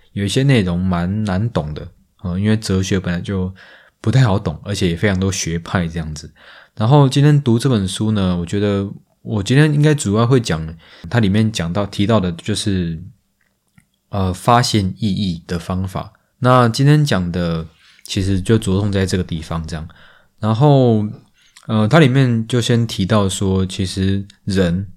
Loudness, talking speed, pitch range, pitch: -17 LUFS, 250 characters per minute, 90-110 Hz, 100 Hz